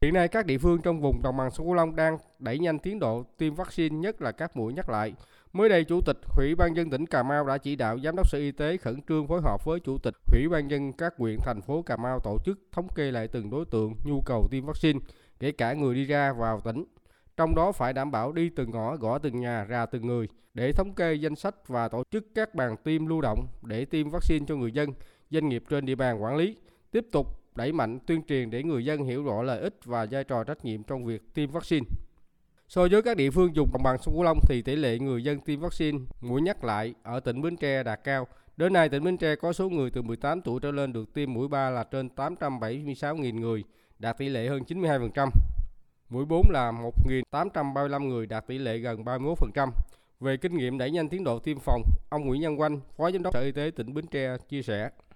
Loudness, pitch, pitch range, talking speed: -29 LUFS, 140 Hz, 120-160 Hz, 245 wpm